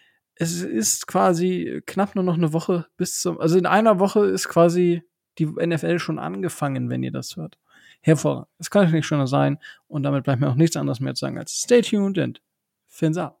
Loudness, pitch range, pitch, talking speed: -22 LUFS, 150-185 Hz, 165 Hz, 210 wpm